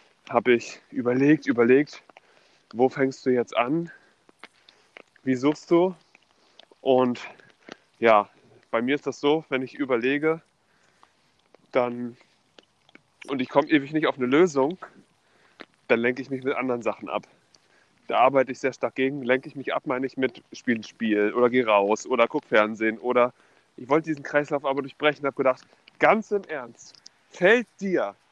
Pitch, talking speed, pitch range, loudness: 135 Hz, 155 wpm, 125-150 Hz, -24 LUFS